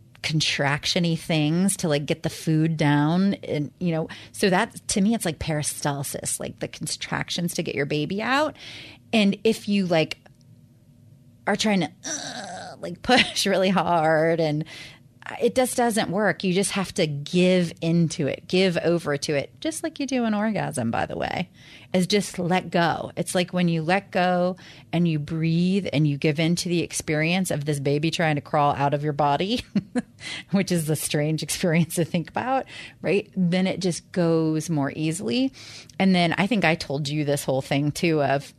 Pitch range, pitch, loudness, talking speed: 150-190 Hz, 170 Hz, -24 LUFS, 185 wpm